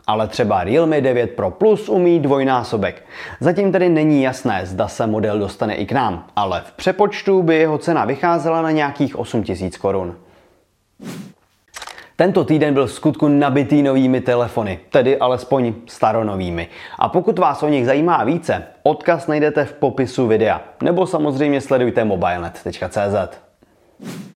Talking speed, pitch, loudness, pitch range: 140 wpm, 135 Hz, -17 LUFS, 110-155 Hz